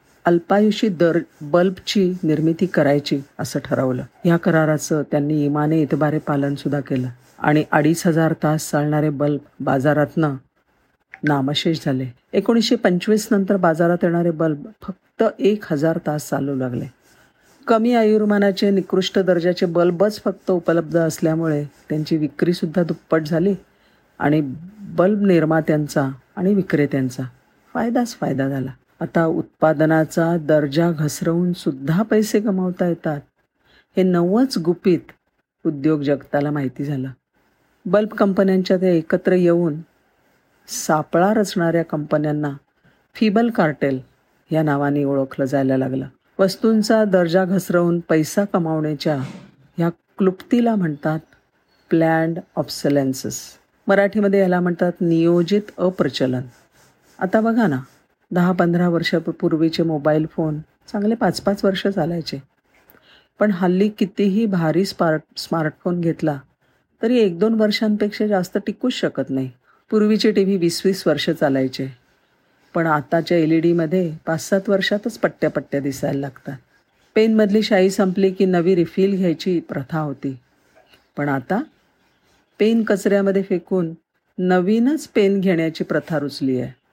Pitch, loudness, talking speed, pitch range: 170 Hz, -19 LUFS, 115 wpm, 150-195 Hz